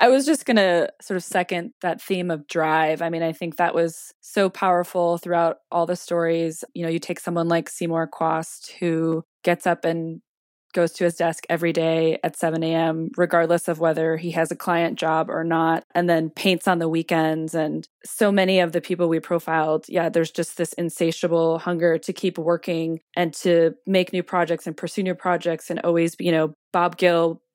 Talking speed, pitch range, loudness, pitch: 205 wpm, 165-175 Hz, -22 LUFS, 170 Hz